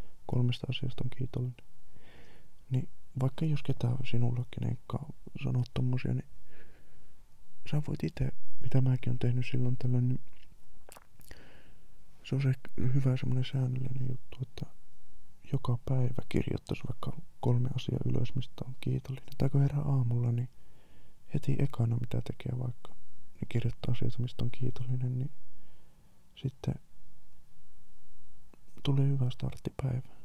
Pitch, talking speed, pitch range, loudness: 125 Hz, 125 wpm, 120-130 Hz, -34 LUFS